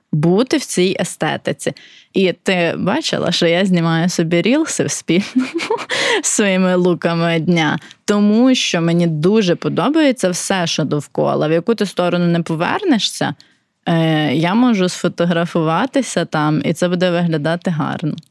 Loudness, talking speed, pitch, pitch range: -16 LUFS, 130 wpm, 175 Hz, 170-215 Hz